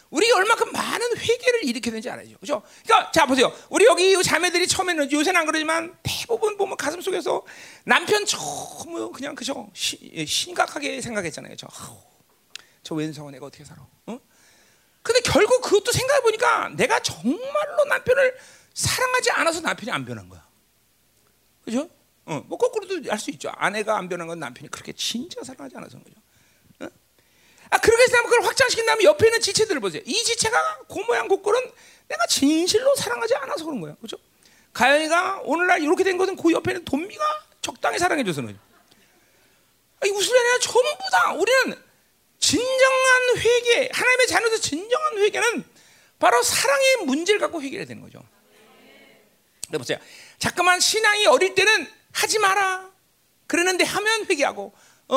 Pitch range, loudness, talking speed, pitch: 285-455 Hz, -21 LUFS, 355 characters per minute, 370 Hz